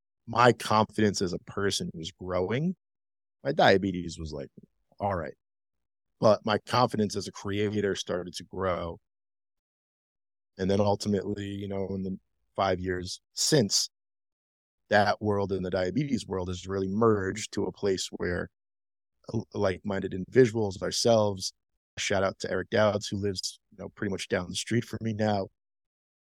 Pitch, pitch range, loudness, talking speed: 95 Hz, 90-105 Hz, -28 LUFS, 150 wpm